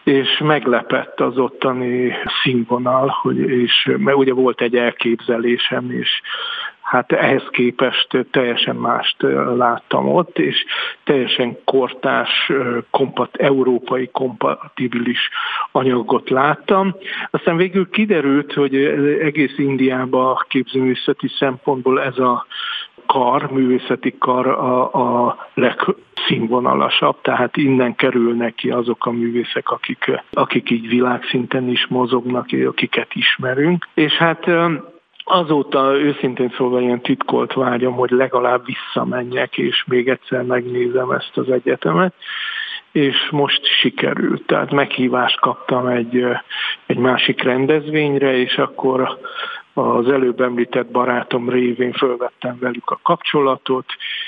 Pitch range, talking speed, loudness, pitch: 125-140 Hz, 110 wpm, -17 LUFS, 130 Hz